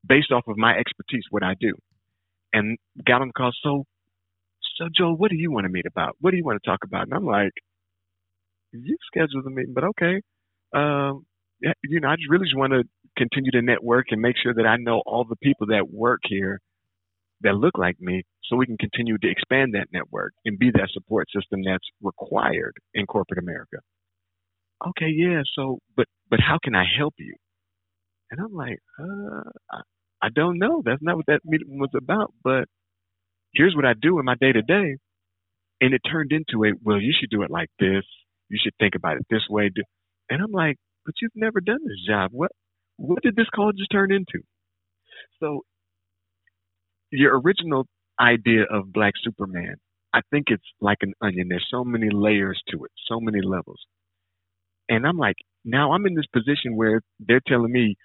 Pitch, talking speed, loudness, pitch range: 115 Hz, 195 wpm, -23 LUFS, 90-145 Hz